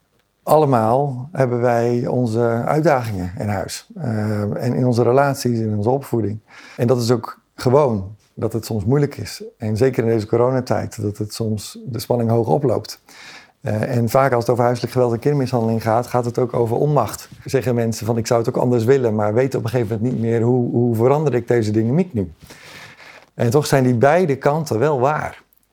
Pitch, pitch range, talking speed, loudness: 120 Hz, 115-130 Hz, 200 wpm, -19 LUFS